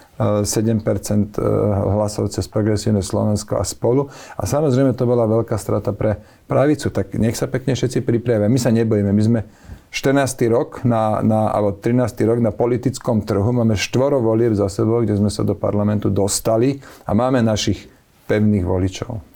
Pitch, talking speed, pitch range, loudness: 110 Hz, 160 wpm, 105-120 Hz, -18 LUFS